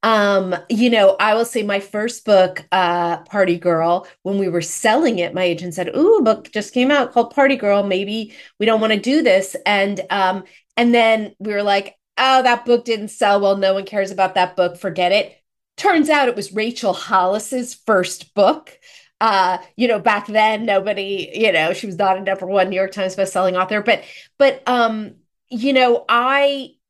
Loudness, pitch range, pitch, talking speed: -17 LUFS, 190-235 Hz, 205 Hz, 200 wpm